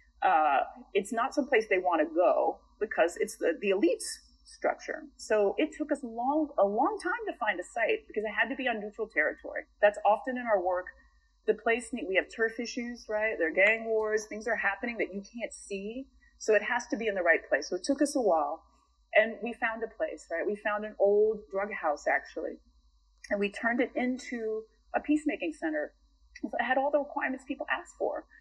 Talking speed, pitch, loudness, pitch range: 215 wpm, 230 Hz, -30 LUFS, 210-290 Hz